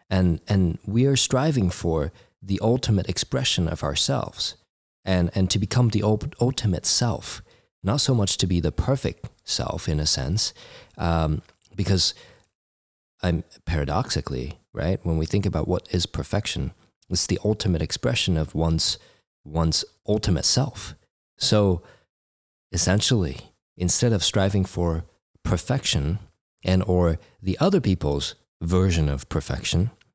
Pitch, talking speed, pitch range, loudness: 90 Hz, 130 wpm, 80-105 Hz, -24 LUFS